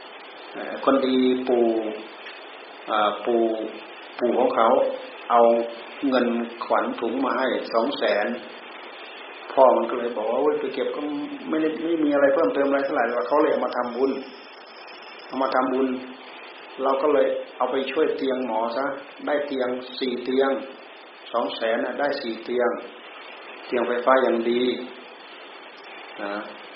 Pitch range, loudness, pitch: 120-150 Hz, -23 LUFS, 130 Hz